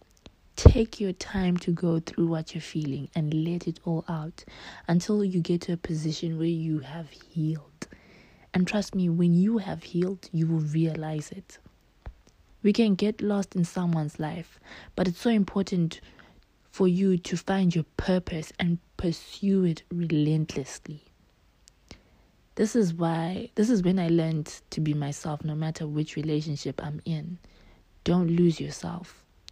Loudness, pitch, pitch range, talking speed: -27 LUFS, 170 Hz, 155-185 Hz, 155 wpm